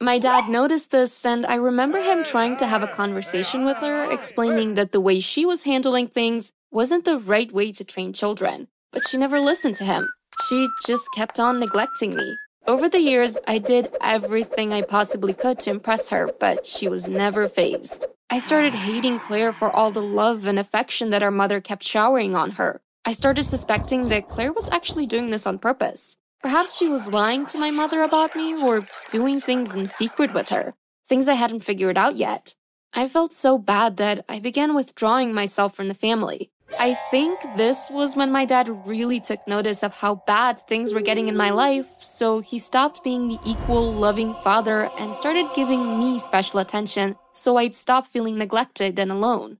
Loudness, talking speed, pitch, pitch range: -22 LUFS, 195 wpm, 235 Hz, 210-270 Hz